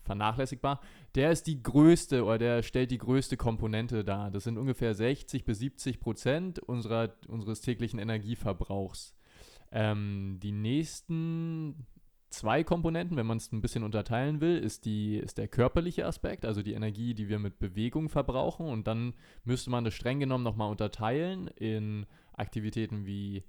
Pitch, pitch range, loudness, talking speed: 115 Hz, 110-135 Hz, -32 LUFS, 155 wpm